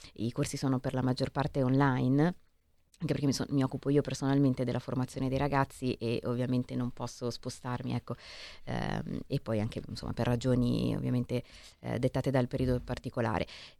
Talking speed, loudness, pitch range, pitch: 170 wpm, -32 LUFS, 120-135 Hz, 125 Hz